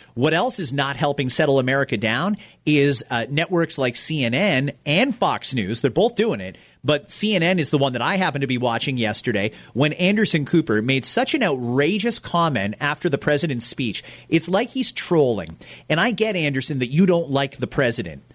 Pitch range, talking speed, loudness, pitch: 130-180 Hz, 190 wpm, -20 LUFS, 145 Hz